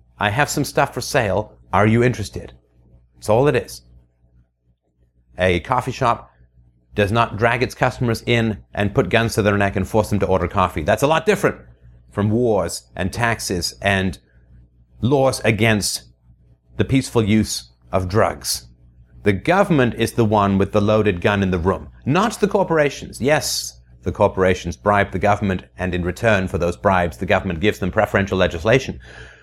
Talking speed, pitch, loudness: 170 wpm, 95 Hz, -19 LUFS